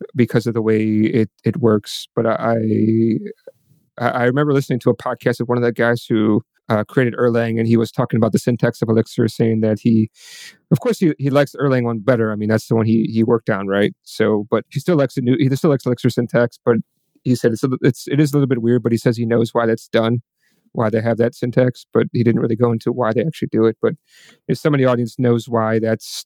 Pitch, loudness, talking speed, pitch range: 120 Hz, -18 LUFS, 255 wpm, 115-130 Hz